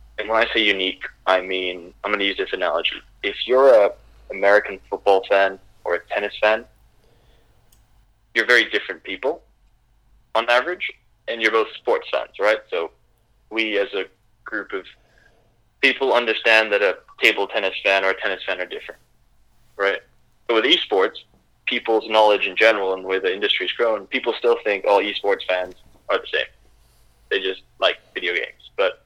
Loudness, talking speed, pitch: -20 LUFS, 170 wpm, 110 Hz